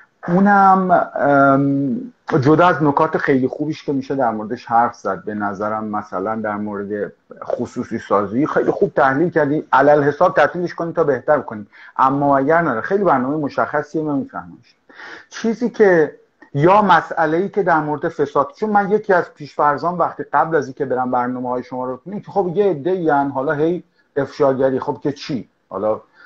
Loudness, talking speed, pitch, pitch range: -18 LUFS, 165 wpm, 150 Hz, 130-175 Hz